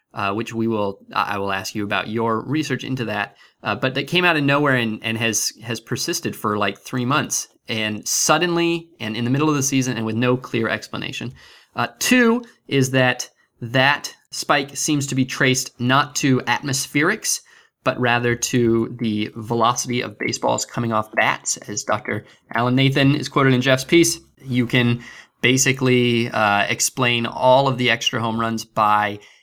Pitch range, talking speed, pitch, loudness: 115-135 Hz, 175 wpm, 125 Hz, -20 LUFS